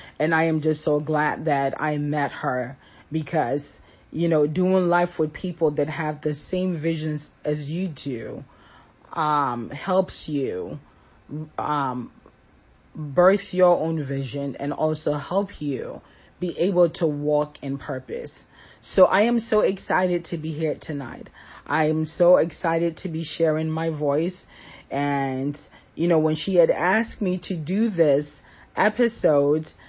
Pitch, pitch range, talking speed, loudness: 155 Hz, 145-175 Hz, 145 wpm, -23 LUFS